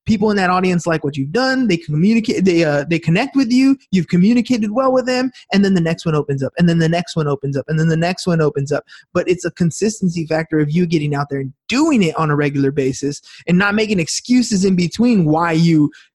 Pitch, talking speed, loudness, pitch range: 170 Hz, 250 wpm, -16 LUFS, 155-210 Hz